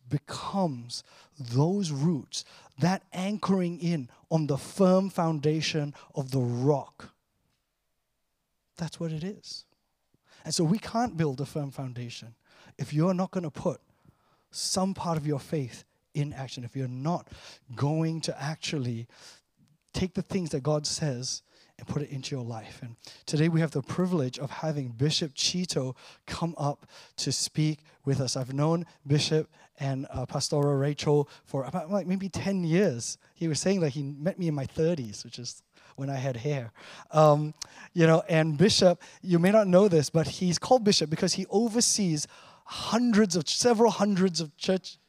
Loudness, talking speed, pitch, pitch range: -28 LUFS, 165 wpm, 155 Hz, 140-180 Hz